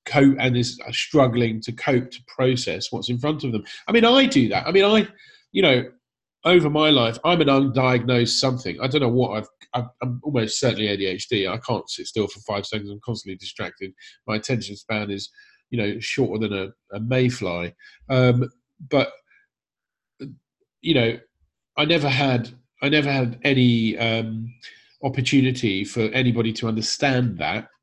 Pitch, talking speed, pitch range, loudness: 125 Hz, 170 wpm, 110-140 Hz, -21 LUFS